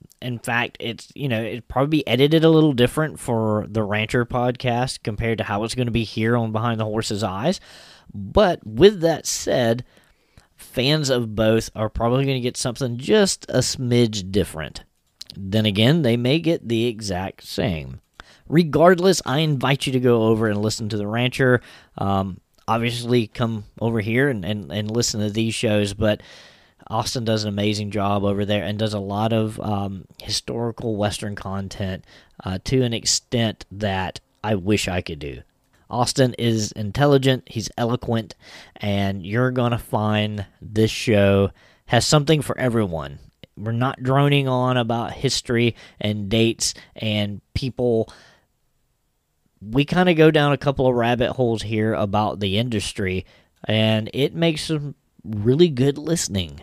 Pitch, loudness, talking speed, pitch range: 115 Hz, -21 LUFS, 160 wpm, 105-125 Hz